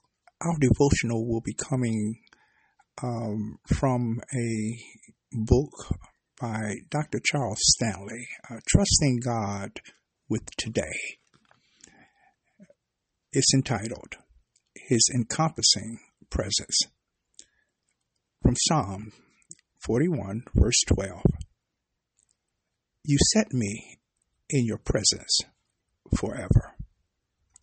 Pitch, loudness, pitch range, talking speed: 115 Hz, -26 LUFS, 110-135 Hz, 75 wpm